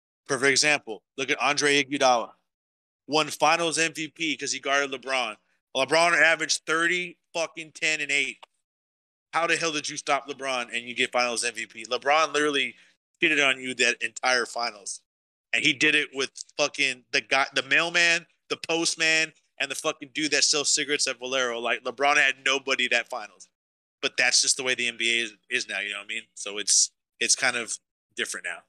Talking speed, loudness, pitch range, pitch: 185 wpm, -24 LUFS, 125-155 Hz, 140 Hz